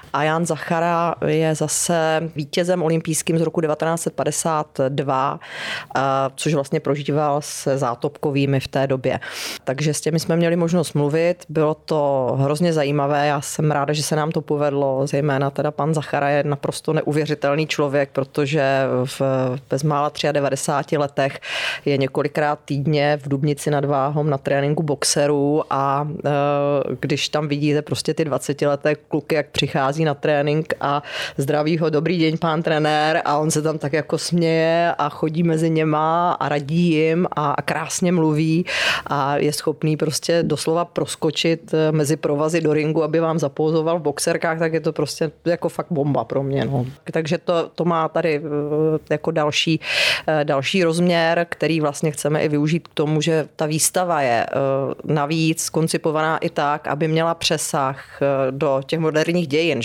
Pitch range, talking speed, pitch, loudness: 145-160 Hz, 155 wpm, 150 Hz, -20 LUFS